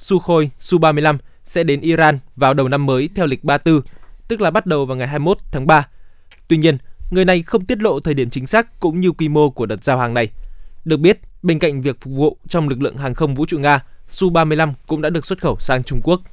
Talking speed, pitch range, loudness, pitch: 240 wpm, 135-170 Hz, -17 LUFS, 150 Hz